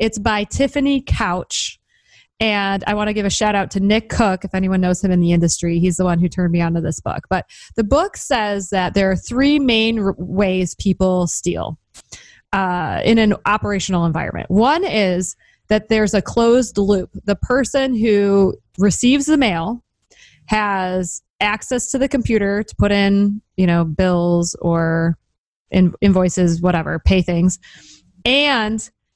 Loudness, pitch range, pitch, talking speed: -17 LUFS, 180-220 Hz, 200 Hz, 165 wpm